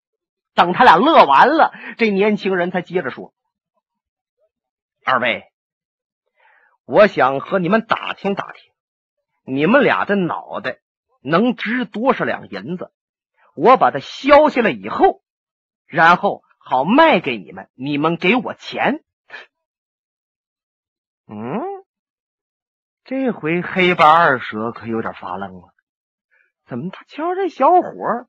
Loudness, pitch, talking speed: -16 LUFS, 215 Hz, 170 characters per minute